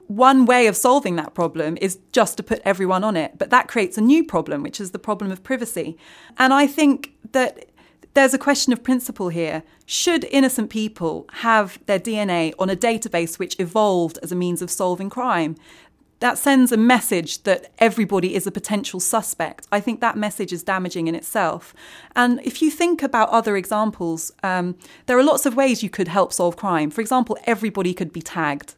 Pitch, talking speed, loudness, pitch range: 215 Hz, 195 wpm, -20 LUFS, 180-250 Hz